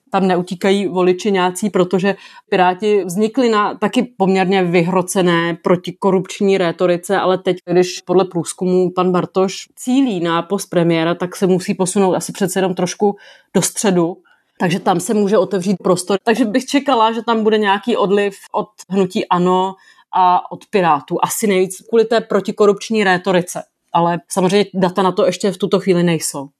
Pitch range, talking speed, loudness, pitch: 180-205 Hz, 160 wpm, -16 LUFS, 190 Hz